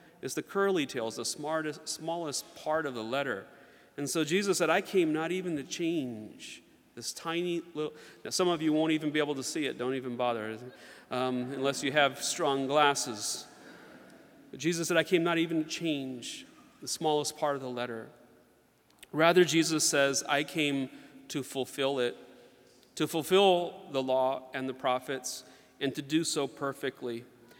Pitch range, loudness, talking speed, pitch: 130-160 Hz, -31 LUFS, 170 wpm, 145 Hz